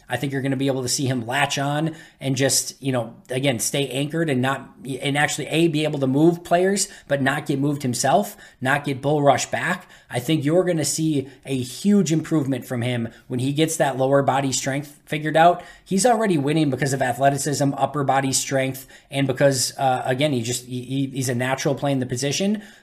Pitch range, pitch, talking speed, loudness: 130-155 Hz, 140 Hz, 220 wpm, -22 LUFS